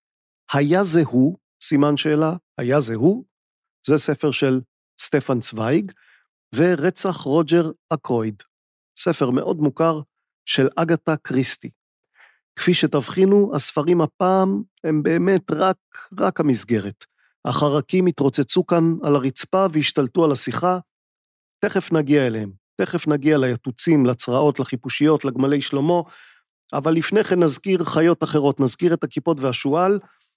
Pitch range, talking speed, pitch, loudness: 140-175 Hz, 115 wpm, 155 Hz, -20 LUFS